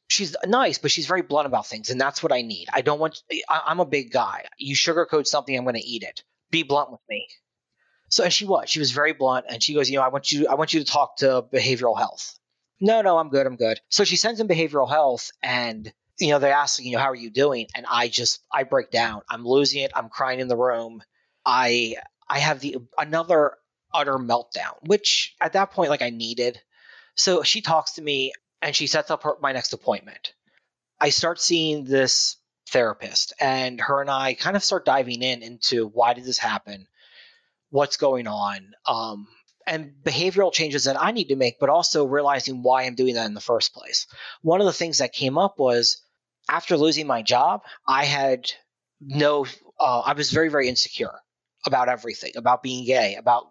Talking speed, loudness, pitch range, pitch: 215 wpm, -22 LUFS, 125-160 Hz, 140 Hz